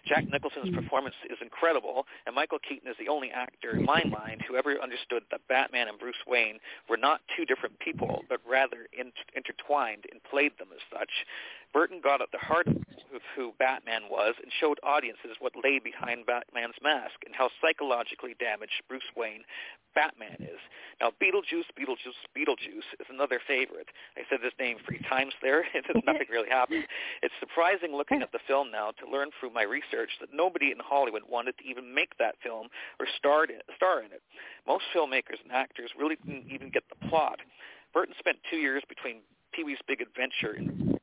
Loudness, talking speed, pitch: -30 LUFS, 185 wpm, 150 Hz